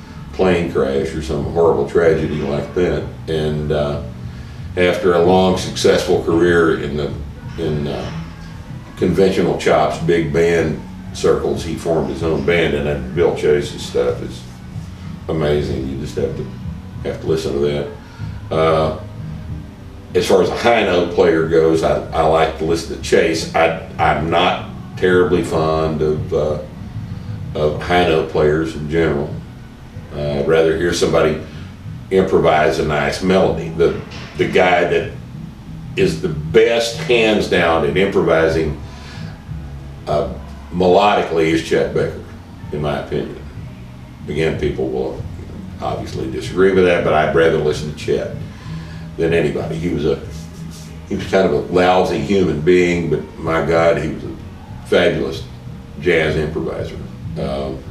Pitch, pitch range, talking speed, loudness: 80 Hz, 75-90 Hz, 140 wpm, -17 LUFS